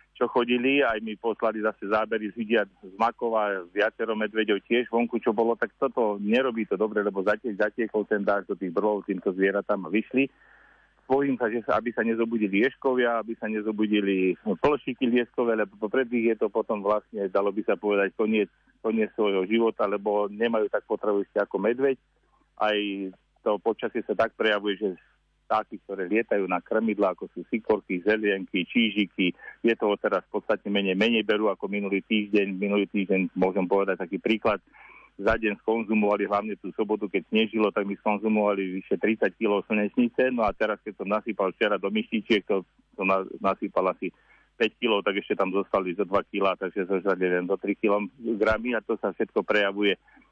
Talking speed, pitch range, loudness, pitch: 180 wpm, 100-115 Hz, -26 LUFS, 105 Hz